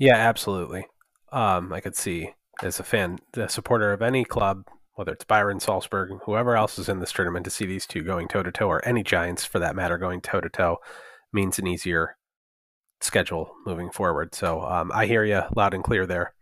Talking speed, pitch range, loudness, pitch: 210 wpm, 90-110 Hz, -25 LUFS, 100 Hz